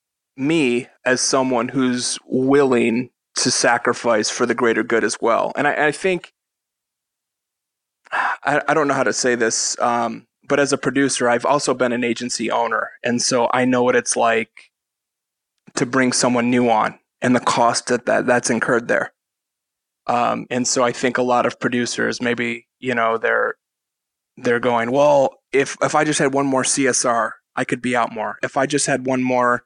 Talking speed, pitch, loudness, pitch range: 180 wpm, 125 Hz, -19 LUFS, 120-140 Hz